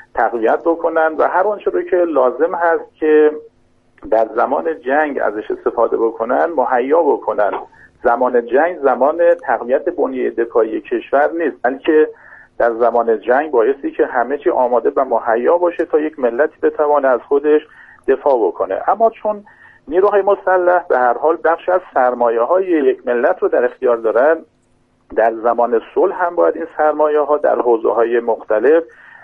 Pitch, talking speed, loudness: 185 Hz, 150 wpm, -15 LUFS